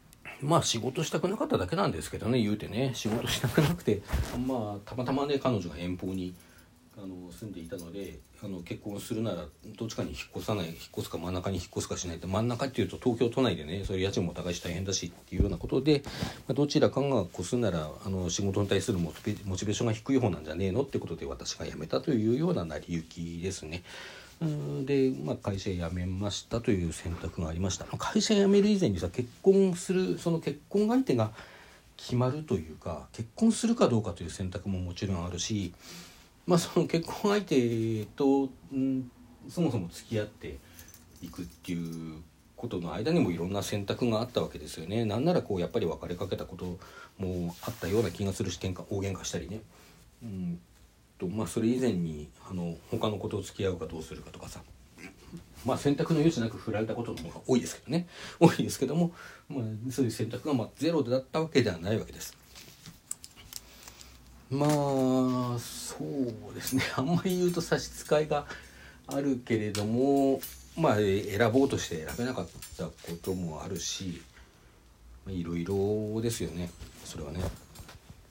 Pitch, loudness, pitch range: 105 Hz, -31 LUFS, 90-130 Hz